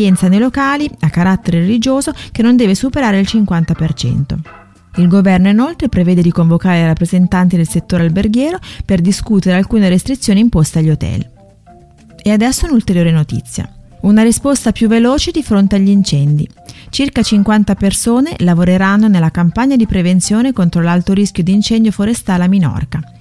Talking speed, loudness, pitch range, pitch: 145 wpm, -12 LUFS, 170-225 Hz, 195 Hz